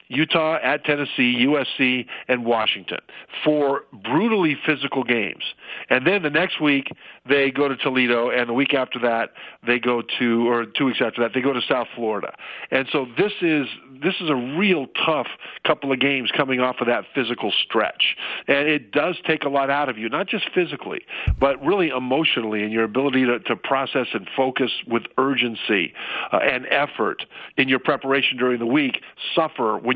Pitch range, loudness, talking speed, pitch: 120-145 Hz, -21 LUFS, 180 wpm, 135 Hz